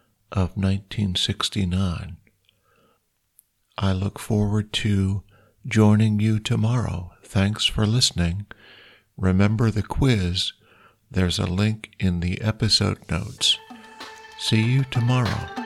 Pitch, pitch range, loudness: 105 Hz, 95-115 Hz, -23 LUFS